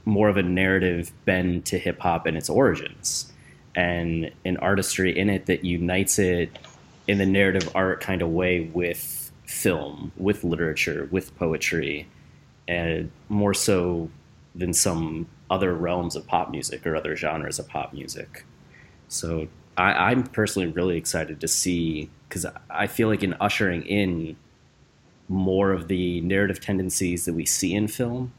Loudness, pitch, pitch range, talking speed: -24 LUFS, 90 Hz, 85-100 Hz, 155 wpm